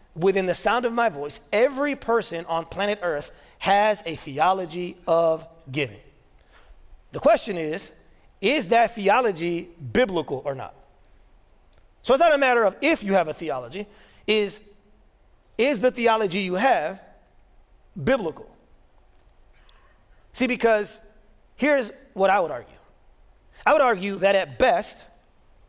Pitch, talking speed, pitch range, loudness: 200 Hz, 130 wpm, 170-235 Hz, -23 LUFS